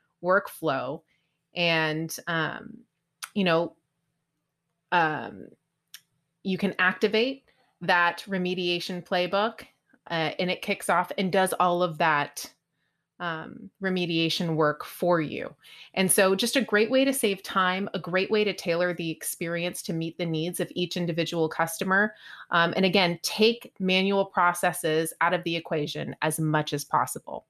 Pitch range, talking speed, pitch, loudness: 165-195 Hz, 140 wpm, 180 Hz, -26 LUFS